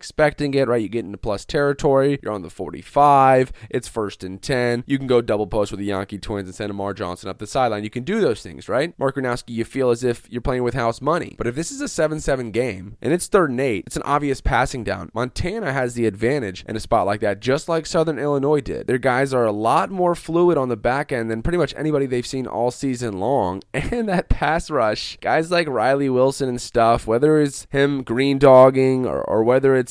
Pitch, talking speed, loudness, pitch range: 125 Hz, 240 wpm, -20 LUFS, 115-140 Hz